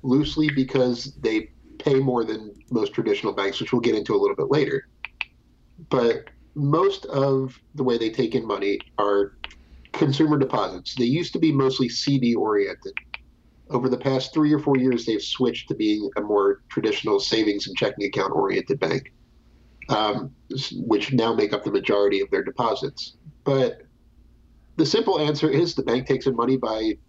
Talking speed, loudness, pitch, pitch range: 170 wpm, -23 LUFS, 135 Hz, 120-170 Hz